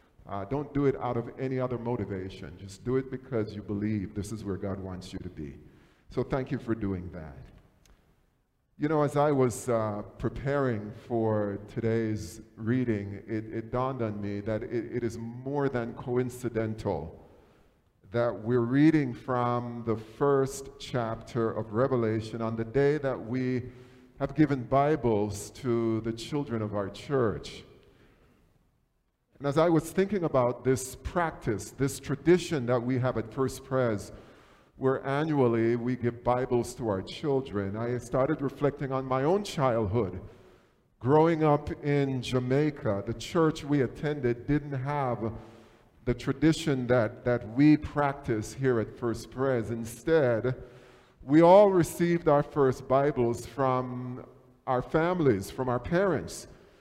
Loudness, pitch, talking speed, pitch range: -29 LUFS, 125 Hz, 145 wpm, 110-140 Hz